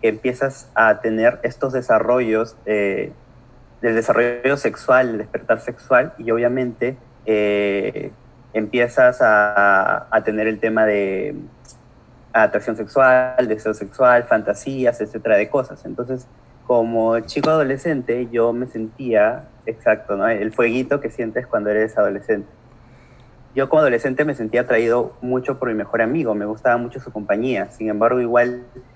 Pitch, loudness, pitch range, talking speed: 120 Hz, -19 LUFS, 110-125 Hz, 135 wpm